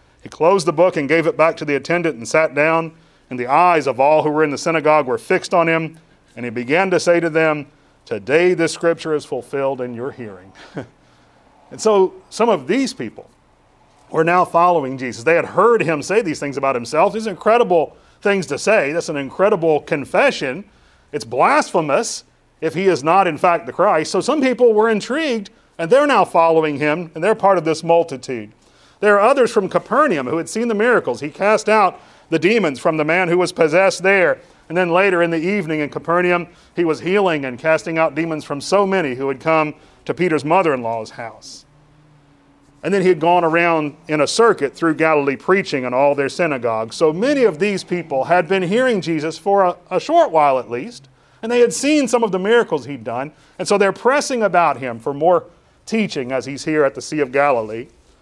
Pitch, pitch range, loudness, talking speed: 165 Hz, 145-190 Hz, -17 LUFS, 210 wpm